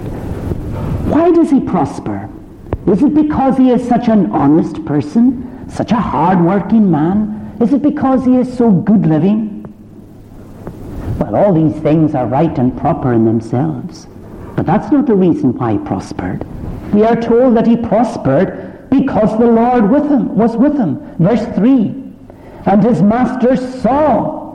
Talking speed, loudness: 155 wpm, -13 LUFS